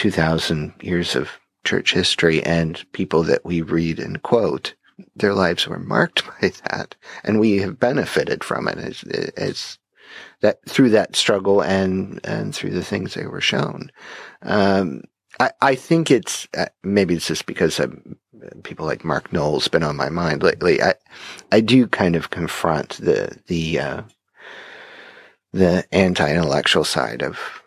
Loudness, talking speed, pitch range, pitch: -20 LUFS, 155 wpm, 85-105 Hz, 95 Hz